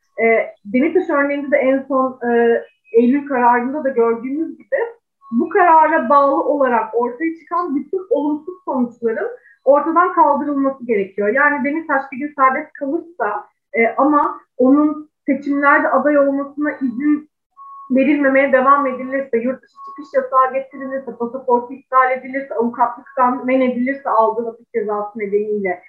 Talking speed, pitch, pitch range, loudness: 130 wpm, 275 Hz, 245-295 Hz, -17 LUFS